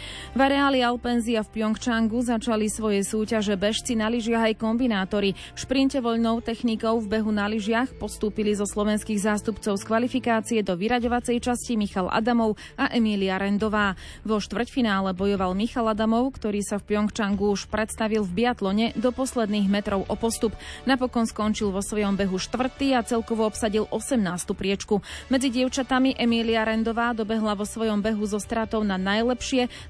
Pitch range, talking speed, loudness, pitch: 210-235 Hz, 155 wpm, -25 LUFS, 220 Hz